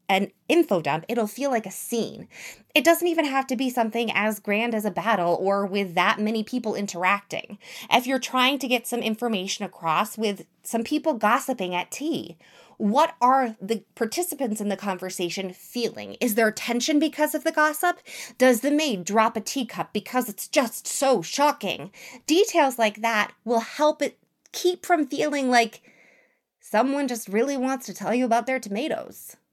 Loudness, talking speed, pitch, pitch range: -24 LUFS, 175 wpm, 230 Hz, 205-270 Hz